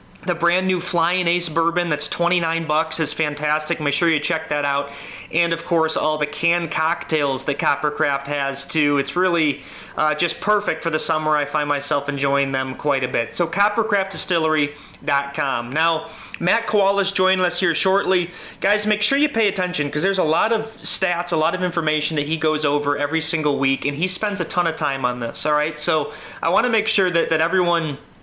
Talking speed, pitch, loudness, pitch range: 205 wpm, 160 Hz, -20 LUFS, 145-180 Hz